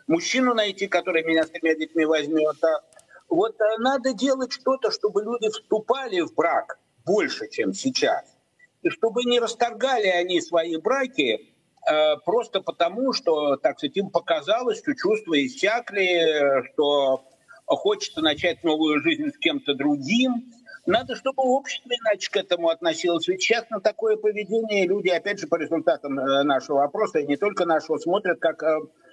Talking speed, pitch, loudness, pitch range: 145 wpm, 205 Hz, -23 LUFS, 165-260 Hz